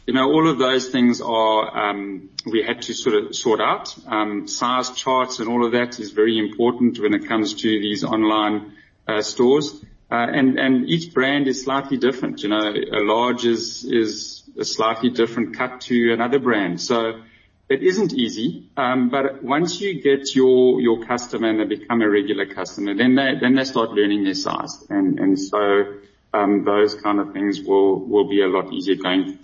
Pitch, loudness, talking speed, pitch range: 120 Hz, -20 LUFS, 195 wpm, 105-135 Hz